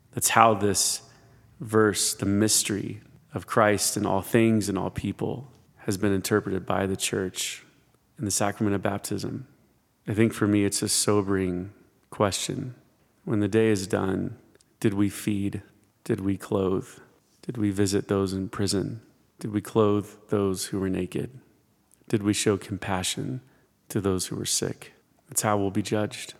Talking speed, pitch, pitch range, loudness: 160 wpm, 105 Hz, 100-110 Hz, -26 LUFS